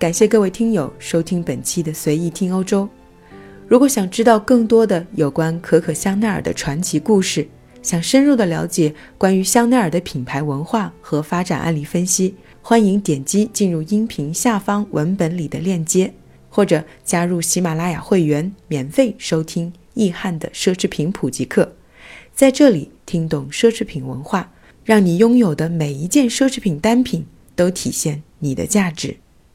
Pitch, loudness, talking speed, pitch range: 175 Hz, -17 LUFS, 260 characters per minute, 155-210 Hz